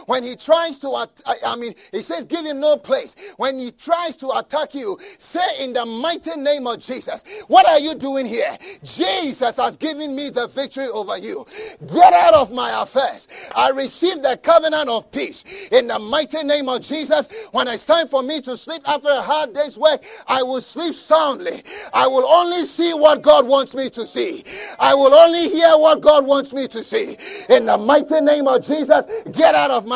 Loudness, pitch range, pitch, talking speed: -17 LUFS, 270-335 Hz, 300 Hz, 200 wpm